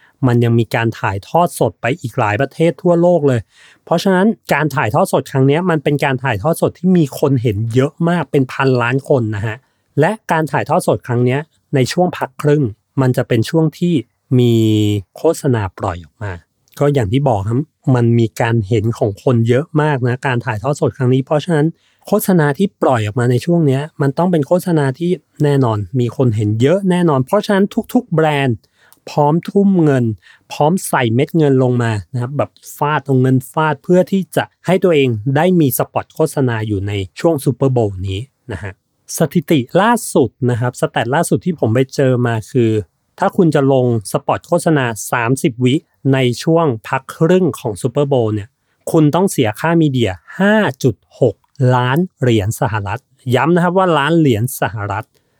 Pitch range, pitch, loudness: 120-165 Hz, 135 Hz, -15 LUFS